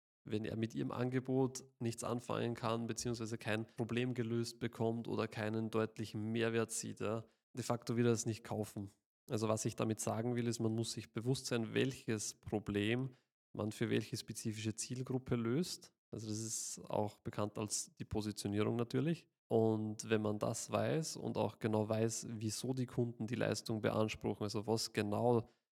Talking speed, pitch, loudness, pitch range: 170 wpm, 115 Hz, -39 LUFS, 110-120 Hz